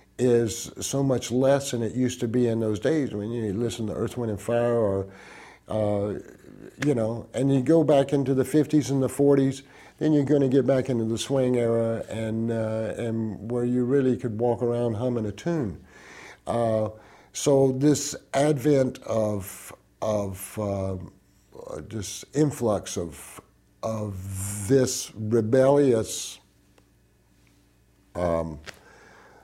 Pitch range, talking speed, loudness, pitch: 105-135 Hz, 145 wpm, -25 LUFS, 115 Hz